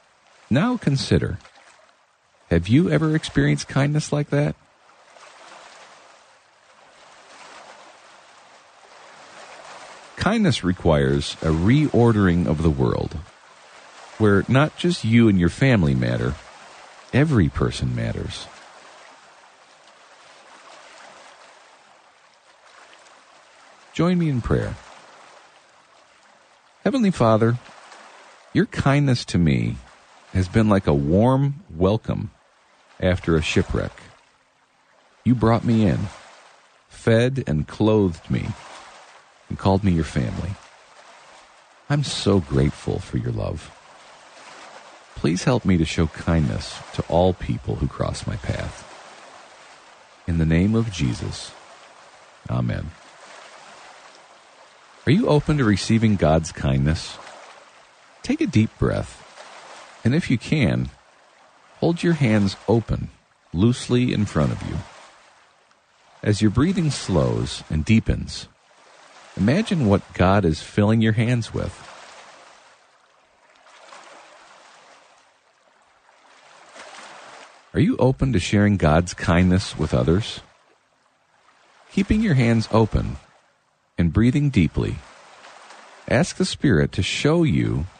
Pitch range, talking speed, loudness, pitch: 80-125 Hz, 100 wpm, -21 LUFS, 105 Hz